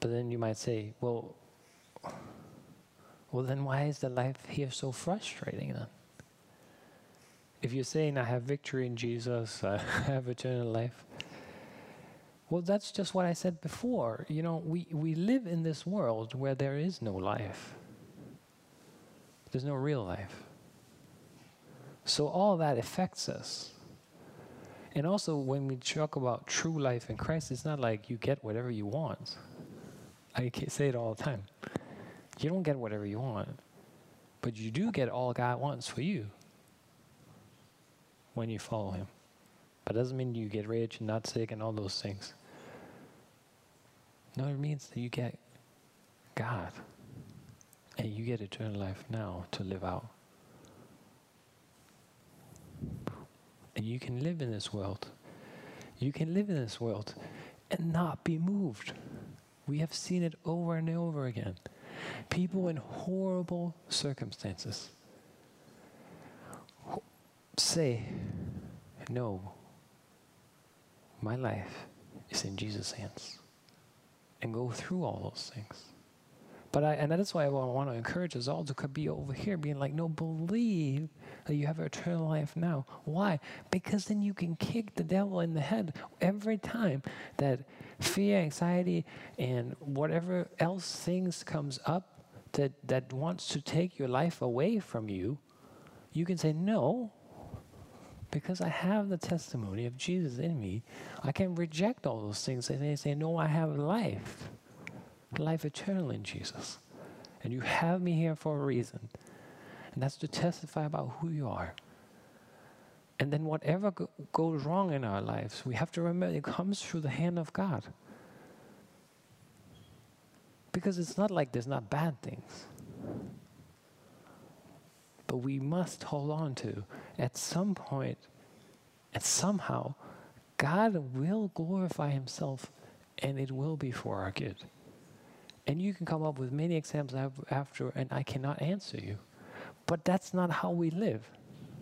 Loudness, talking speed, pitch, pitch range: -35 LUFS, 145 wpm, 145 Hz, 120-170 Hz